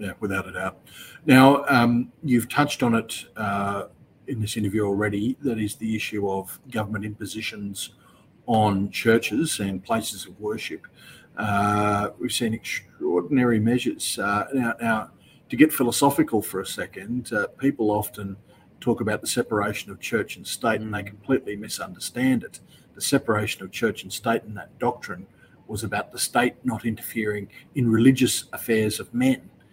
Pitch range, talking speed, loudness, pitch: 105-120 Hz, 155 wpm, -24 LUFS, 110 Hz